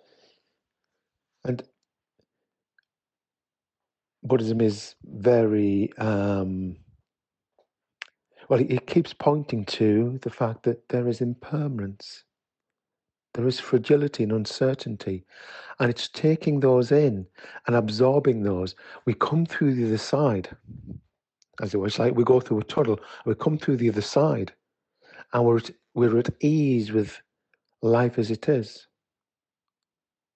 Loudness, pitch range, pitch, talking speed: -24 LUFS, 110-135 Hz, 120 Hz, 120 wpm